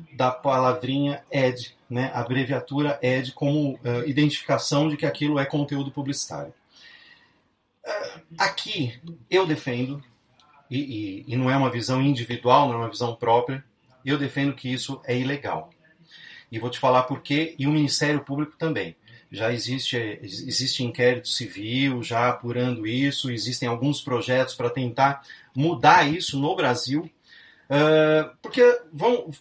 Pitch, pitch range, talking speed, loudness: 135 Hz, 125-150 Hz, 145 wpm, -24 LUFS